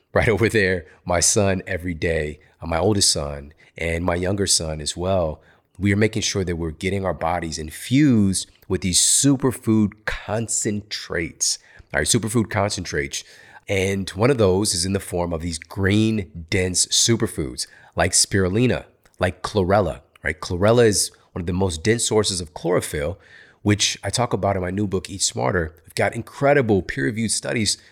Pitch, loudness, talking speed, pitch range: 95 Hz, -21 LUFS, 165 wpm, 85-110 Hz